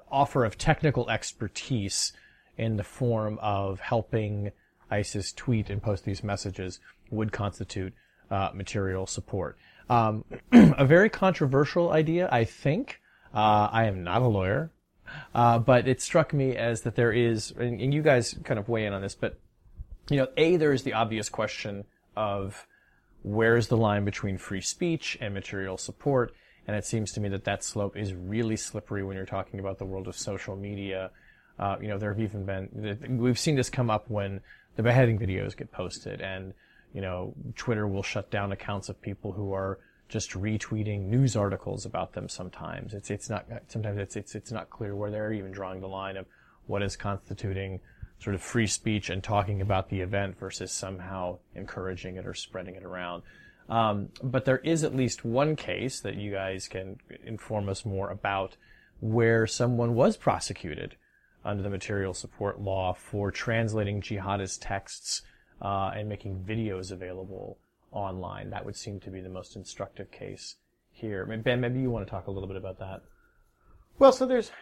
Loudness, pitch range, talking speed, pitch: -29 LUFS, 95-120 Hz, 180 wpm, 105 Hz